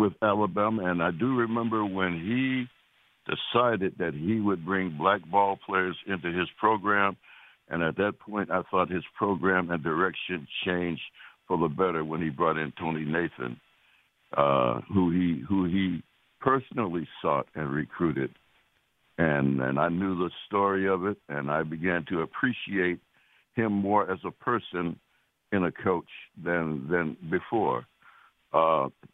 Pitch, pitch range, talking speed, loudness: 90 Hz, 80-100 Hz, 150 wpm, -28 LUFS